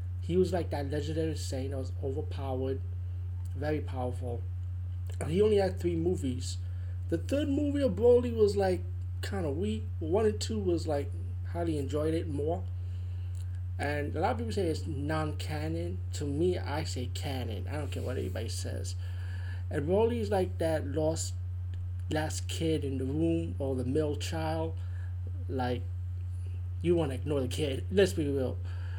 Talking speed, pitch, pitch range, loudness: 170 wpm, 90 Hz, 85-90 Hz, -32 LUFS